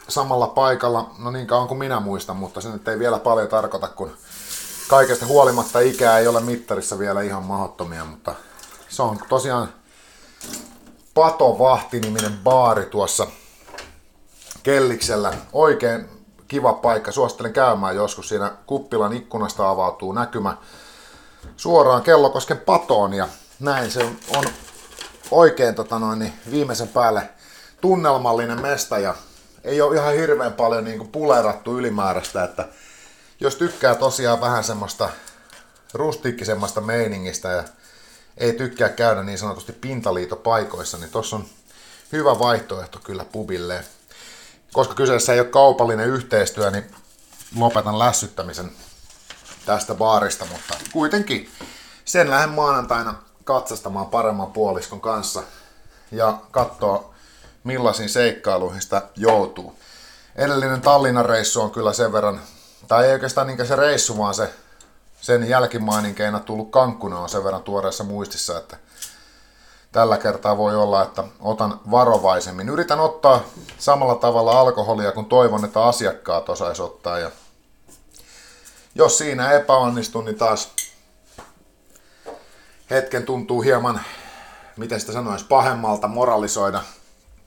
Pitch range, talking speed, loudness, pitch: 105-130 Hz, 120 wpm, -20 LUFS, 115 Hz